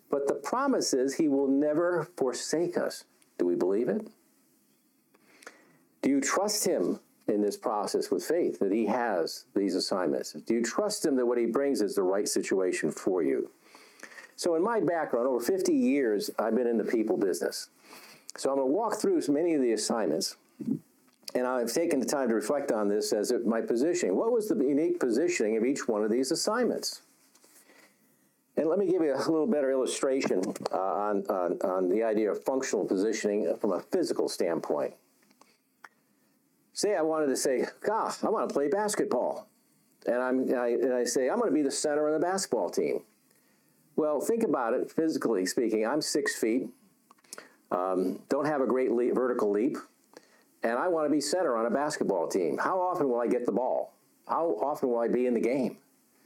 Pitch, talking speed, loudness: 210 Hz, 190 wpm, -29 LUFS